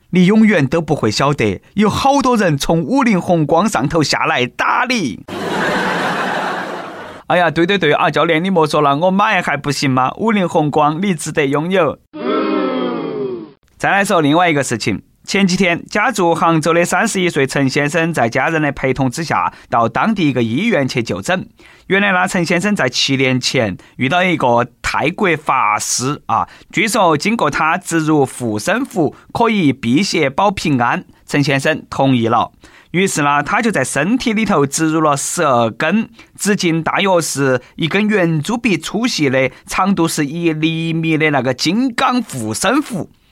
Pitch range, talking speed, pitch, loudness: 140-195 Hz, 245 characters per minute, 165 Hz, -15 LUFS